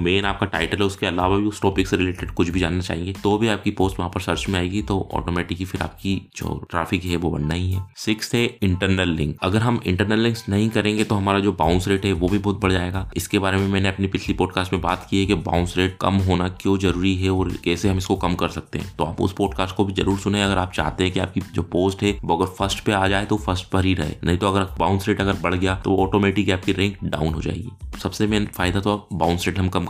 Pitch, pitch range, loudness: 95 Hz, 90-100 Hz, -22 LUFS